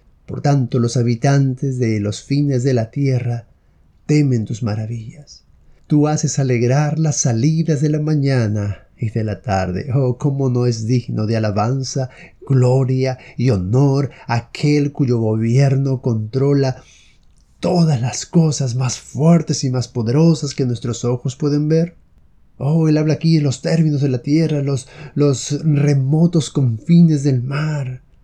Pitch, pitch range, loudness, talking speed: 135 Hz, 120-150 Hz, -17 LUFS, 145 wpm